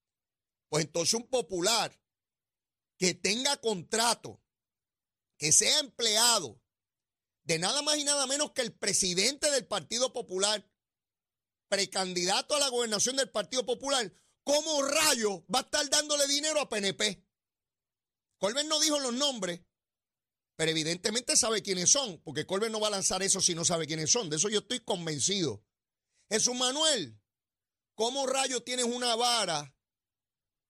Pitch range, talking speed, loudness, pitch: 160-255 Hz, 140 wpm, -28 LUFS, 210 Hz